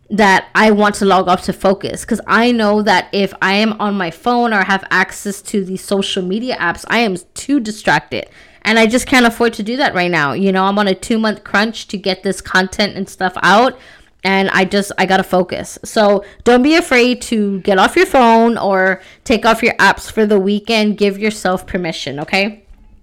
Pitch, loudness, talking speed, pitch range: 200 Hz, -14 LUFS, 215 wpm, 190-225 Hz